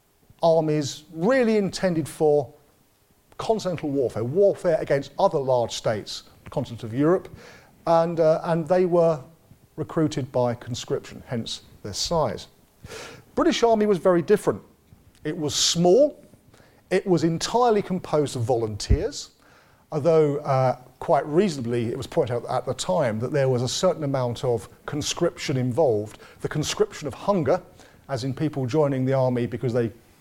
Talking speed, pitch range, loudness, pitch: 145 wpm, 130-175 Hz, -24 LUFS, 150 Hz